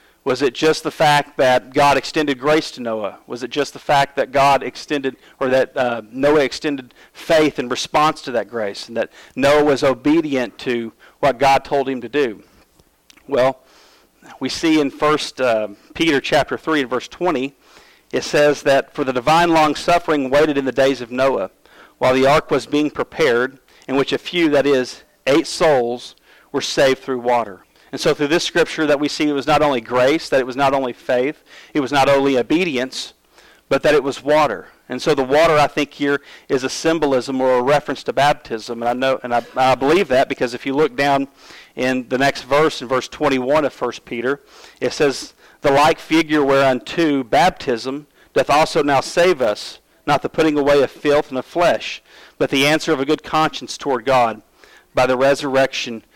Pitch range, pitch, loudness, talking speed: 130-150 Hz, 140 Hz, -18 LUFS, 200 wpm